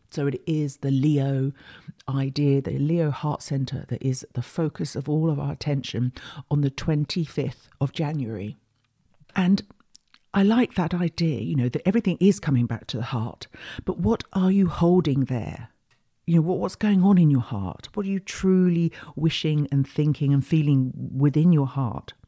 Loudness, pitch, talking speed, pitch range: -24 LUFS, 145 Hz, 175 wpm, 135-170 Hz